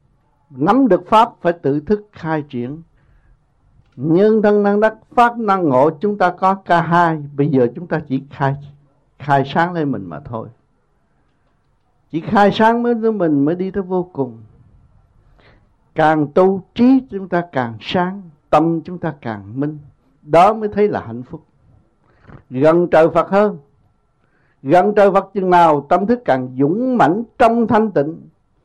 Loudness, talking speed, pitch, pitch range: -16 LUFS, 165 wpm, 160 Hz, 140-195 Hz